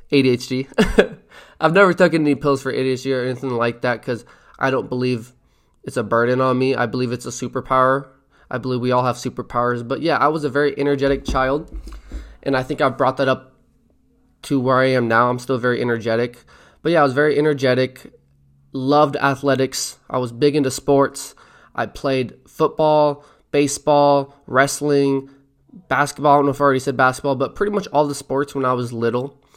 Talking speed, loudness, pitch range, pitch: 190 wpm, -19 LUFS, 125-145 Hz, 135 Hz